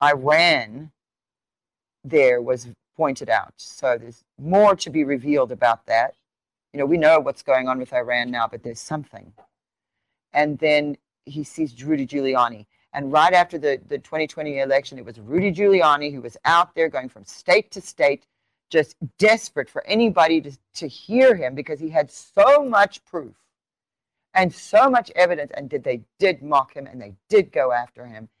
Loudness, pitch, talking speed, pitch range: -20 LUFS, 150 Hz, 175 wpm, 125-180 Hz